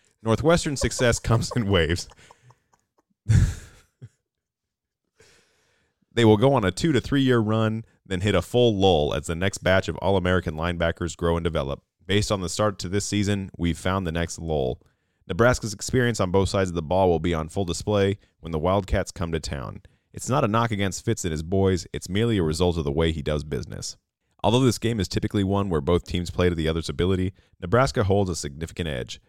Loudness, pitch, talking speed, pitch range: -24 LUFS, 95 Hz, 205 wpm, 85-110 Hz